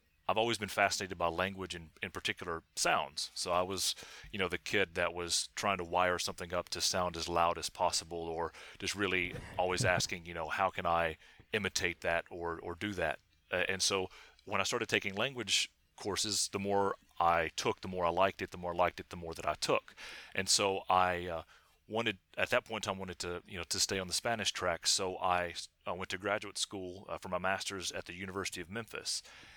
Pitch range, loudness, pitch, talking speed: 85-100 Hz, -34 LUFS, 90 Hz, 225 wpm